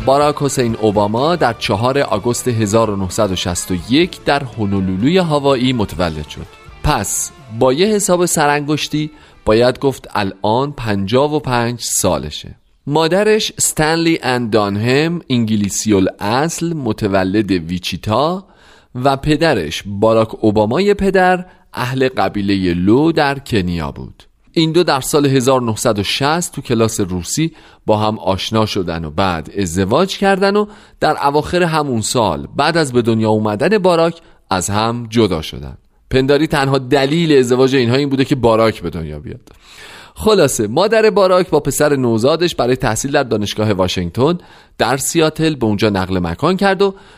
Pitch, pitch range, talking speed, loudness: 125 Hz, 105-155 Hz, 130 wpm, -15 LUFS